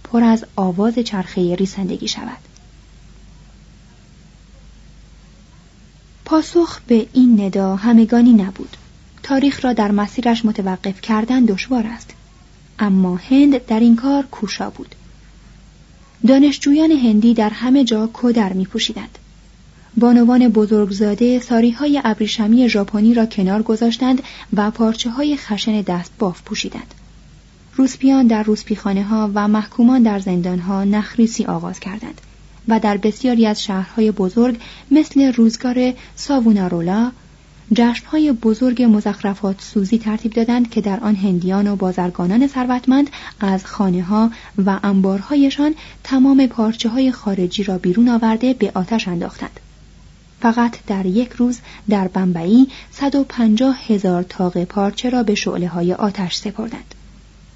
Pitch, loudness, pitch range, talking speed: 220 Hz, -16 LUFS, 200-245 Hz, 120 wpm